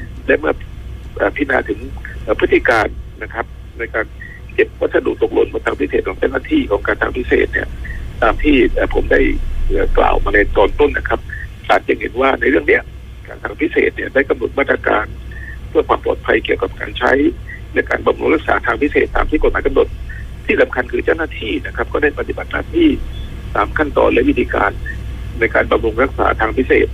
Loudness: -16 LUFS